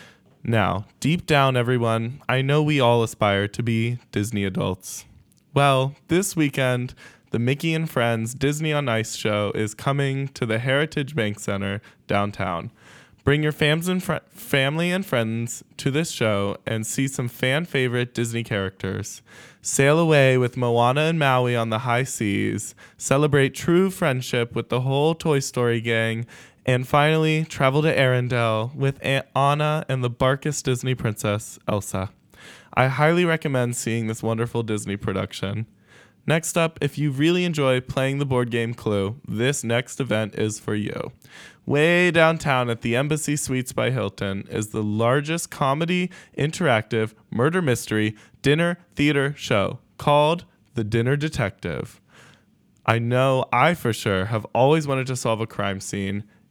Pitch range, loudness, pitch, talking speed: 110-145 Hz, -22 LUFS, 125 Hz, 150 wpm